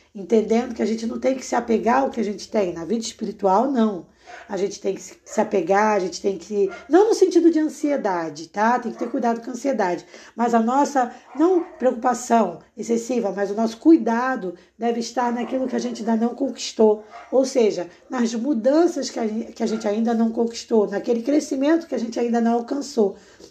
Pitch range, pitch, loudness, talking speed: 210-260 Hz, 235 Hz, -22 LUFS, 200 wpm